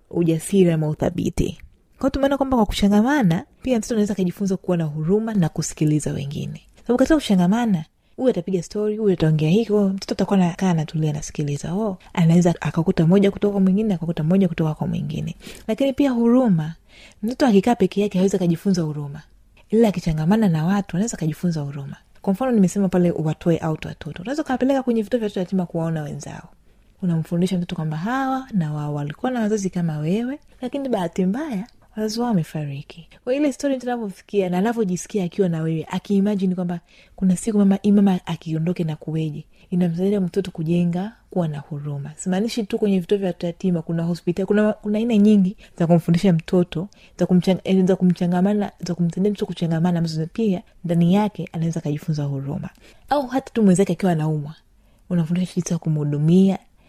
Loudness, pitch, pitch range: -21 LUFS, 185 Hz, 165-210 Hz